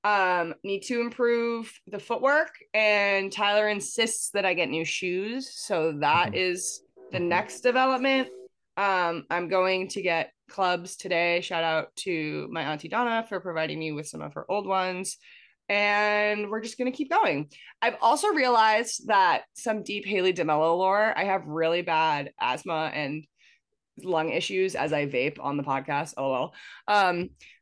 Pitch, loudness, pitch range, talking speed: 190 Hz, -26 LUFS, 165-220 Hz, 160 wpm